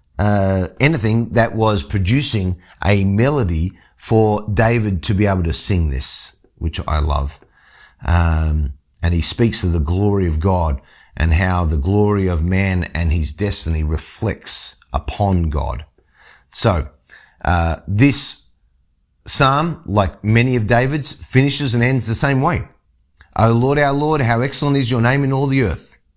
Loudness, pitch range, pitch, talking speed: -17 LUFS, 80-115 Hz, 95 Hz, 150 wpm